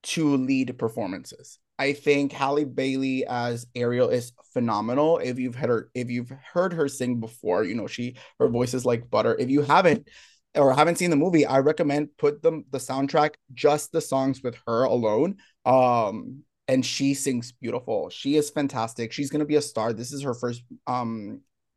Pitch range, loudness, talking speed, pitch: 120-145 Hz, -25 LUFS, 185 wpm, 135 Hz